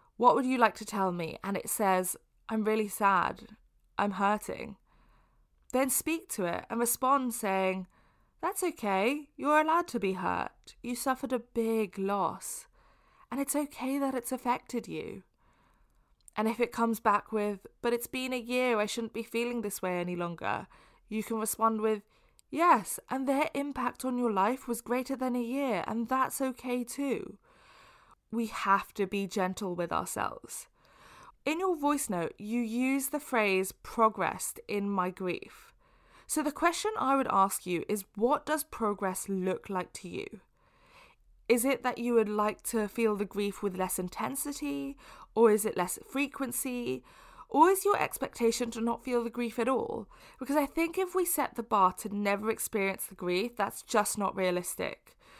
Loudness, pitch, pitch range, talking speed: -31 LUFS, 230 Hz, 200-270 Hz, 175 wpm